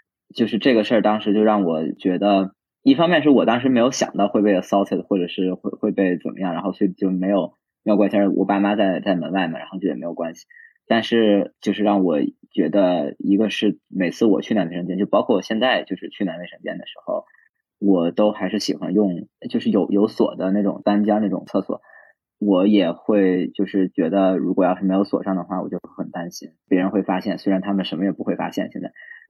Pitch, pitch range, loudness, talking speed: 100 Hz, 95-105 Hz, -20 LUFS, 330 characters per minute